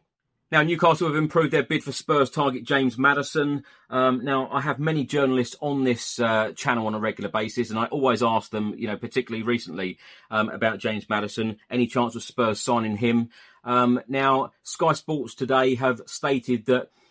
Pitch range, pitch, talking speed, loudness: 115-140 Hz, 125 Hz, 180 wpm, -24 LUFS